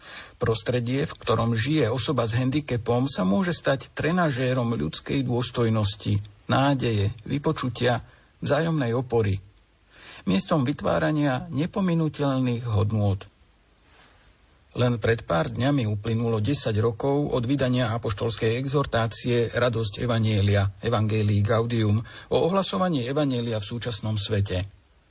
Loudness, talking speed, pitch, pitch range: -25 LUFS, 100 wpm, 120 Hz, 110-140 Hz